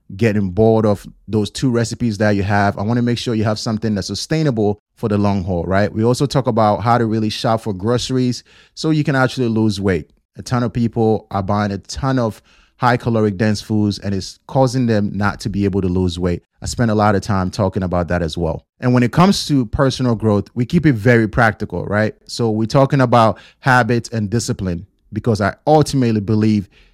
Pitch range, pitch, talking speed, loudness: 100-120 Hz, 110 Hz, 220 wpm, -17 LUFS